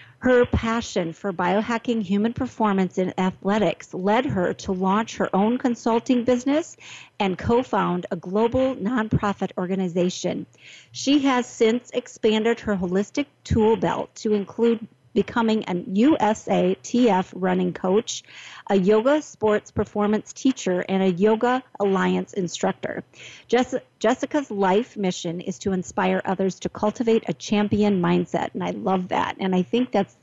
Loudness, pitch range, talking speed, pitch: -23 LUFS, 190-235 Hz, 140 wpm, 210 Hz